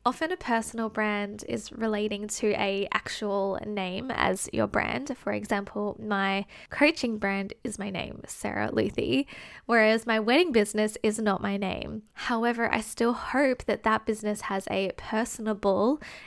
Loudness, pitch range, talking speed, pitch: -28 LUFS, 200-235 Hz, 150 wpm, 215 Hz